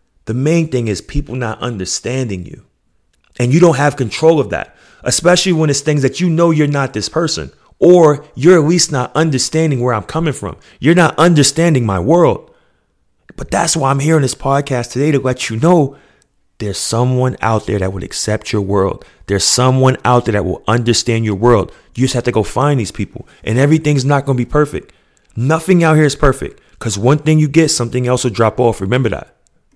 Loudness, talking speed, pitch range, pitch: -13 LUFS, 210 wpm, 115-150 Hz, 130 Hz